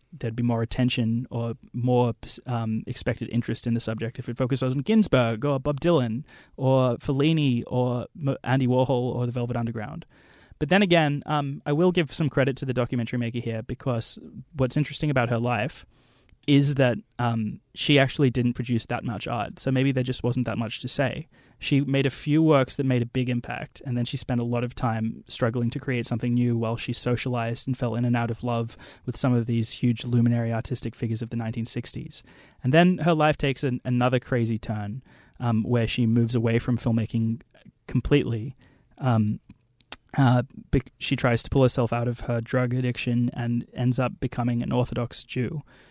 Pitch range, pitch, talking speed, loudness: 120-135 Hz, 125 Hz, 195 wpm, -25 LUFS